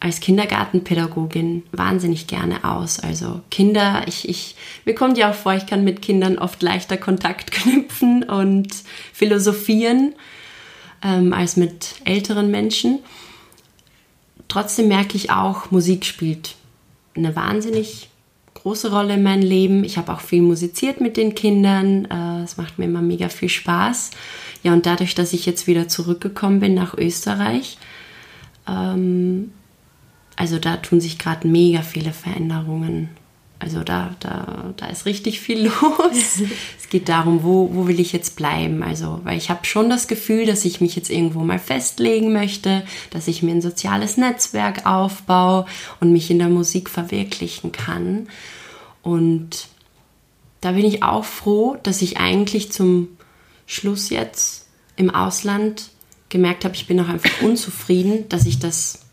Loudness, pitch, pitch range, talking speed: -19 LUFS, 185 Hz, 170-205 Hz, 150 wpm